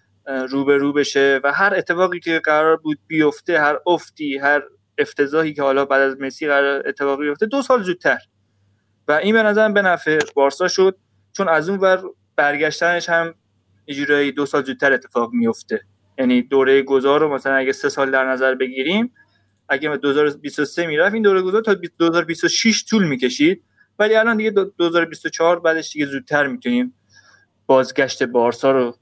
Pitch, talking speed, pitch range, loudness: 145 Hz, 165 wpm, 135-170 Hz, -18 LUFS